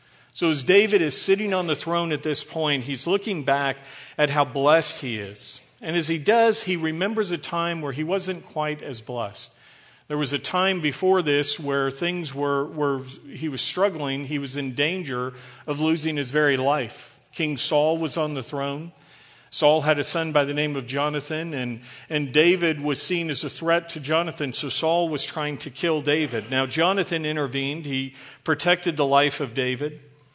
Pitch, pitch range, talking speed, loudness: 150 Hz, 140-165 Hz, 190 wpm, -24 LUFS